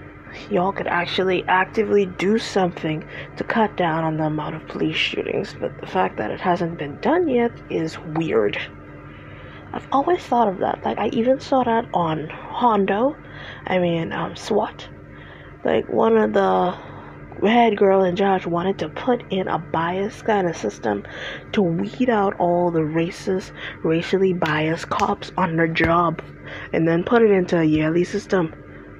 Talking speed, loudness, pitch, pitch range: 165 wpm, -21 LUFS, 185 Hz, 165-205 Hz